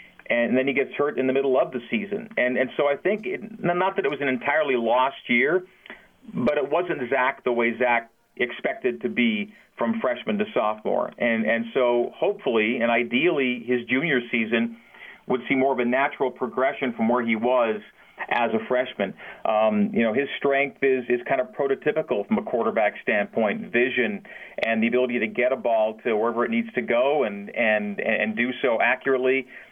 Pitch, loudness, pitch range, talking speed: 125 Hz, -24 LUFS, 115-140 Hz, 195 wpm